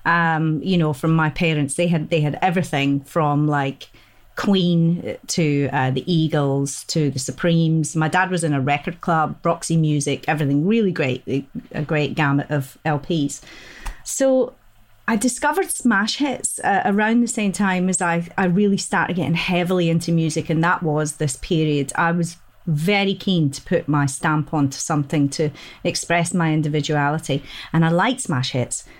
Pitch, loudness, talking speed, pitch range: 160 Hz, -20 LUFS, 170 wpm, 145-180 Hz